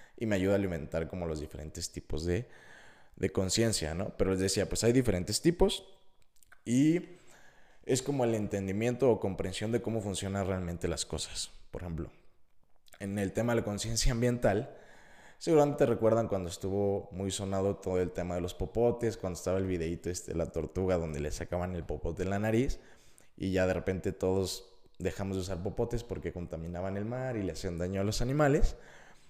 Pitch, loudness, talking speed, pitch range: 95 Hz, -32 LUFS, 185 wpm, 90-115 Hz